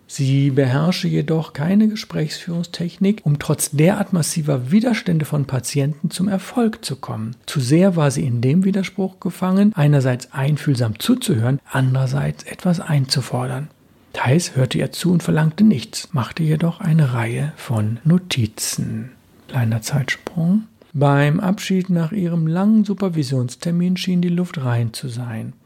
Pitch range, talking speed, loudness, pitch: 135-185 Hz, 135 wpm, -19 LUFS, 155 Hz